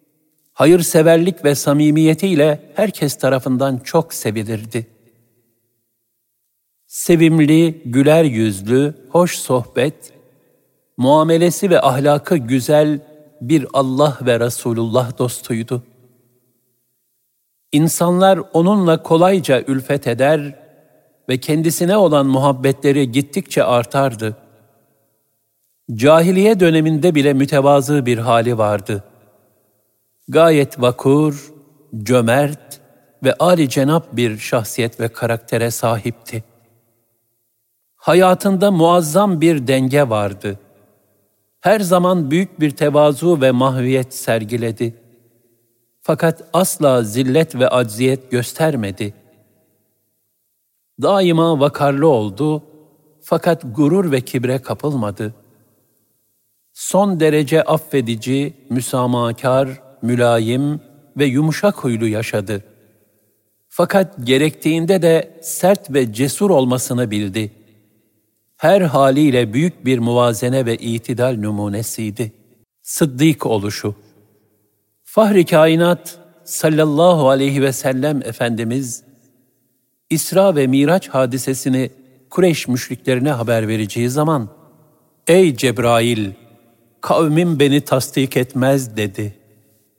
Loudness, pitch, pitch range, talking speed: -16 LUFS, 130 Hz, 115-155 Hz, 85 wpm